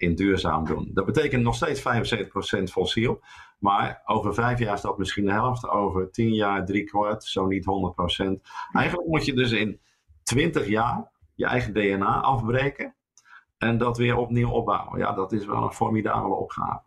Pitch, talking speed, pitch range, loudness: 105 Hz, 175 wpm, 95-120 Hz, -25 LUFS